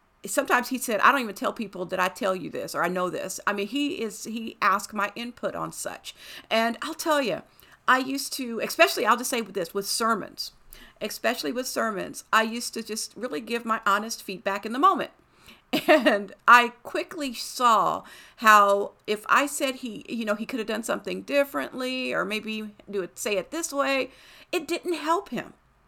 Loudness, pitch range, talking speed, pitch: -25 LUFS, 210-280 Hz, 200 wpm, 235 Hz